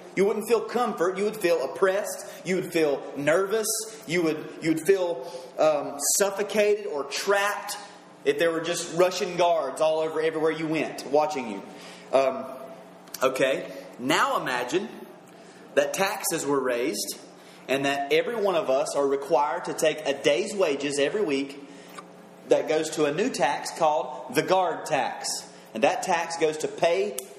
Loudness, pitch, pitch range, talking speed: -26 LUFS, 160 Hz, 140-195 Hz, 160 wpm